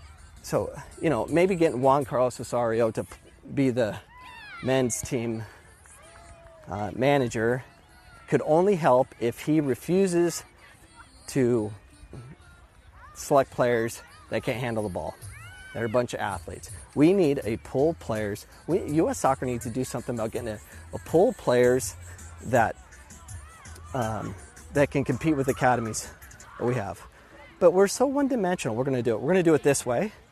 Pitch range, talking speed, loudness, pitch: 95-135 Hz, 160 wpm, -26 LUFS, 120 Hz